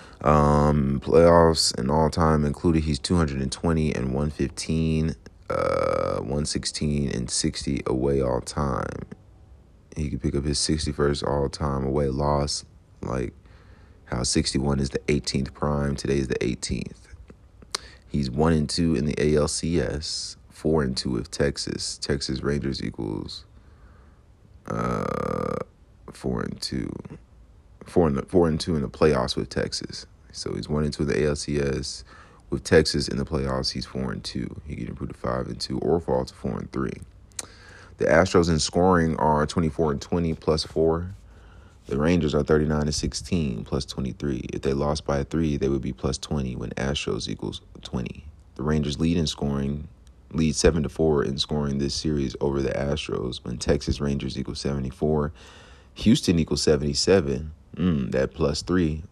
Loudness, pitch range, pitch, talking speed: -25 LUFS, 70-80 Hz, 75 Hz, 170 wpm